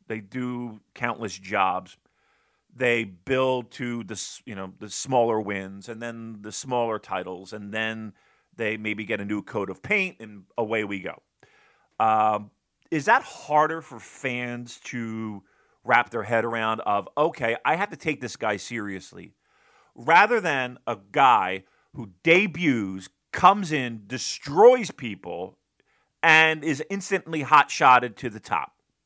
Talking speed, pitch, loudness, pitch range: 145 wpm, 115 Hz, -24 LUFS, 105-135 Hz